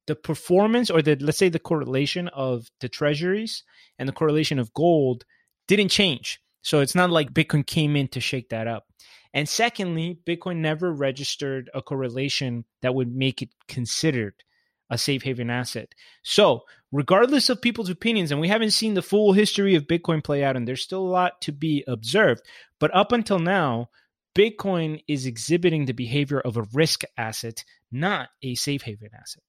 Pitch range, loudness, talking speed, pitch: 130-180 Hz, -23 LUFS, 175 wpm, 150 Hz